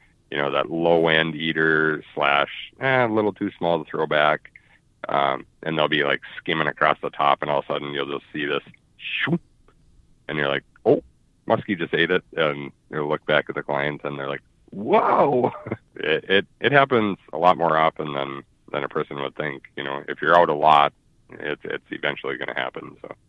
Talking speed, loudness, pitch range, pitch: 210 wpm, -22 LUFS, 70-85 Hz, 75 Hz